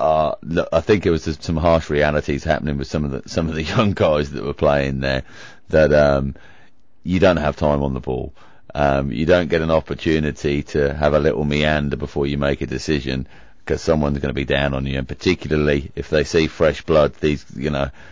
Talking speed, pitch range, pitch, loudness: 220 wpm, 70-80 Hz, 75 Hz, -19 LUFS